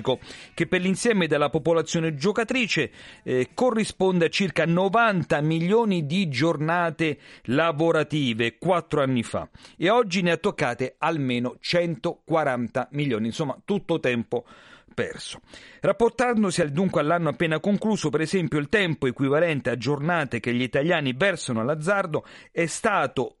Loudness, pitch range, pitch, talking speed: -24 LUFS, 140-190 Hz, 165 Hz, 130 wpm